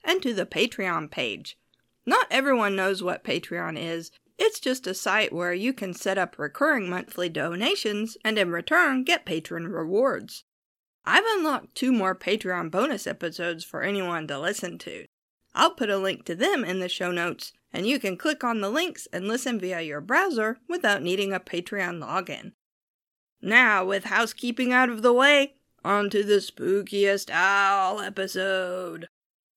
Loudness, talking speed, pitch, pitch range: -25 LUFS, 165 wpm, 200 Hz, 185-255 Hz